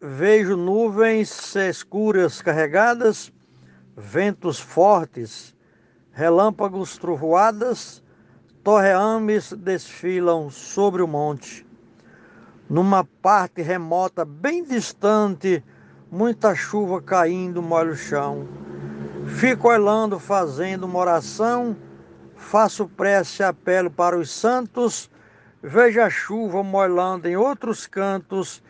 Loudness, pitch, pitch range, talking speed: -20 LUFS, 185 Hz, 160-210 Hz, 90 wpm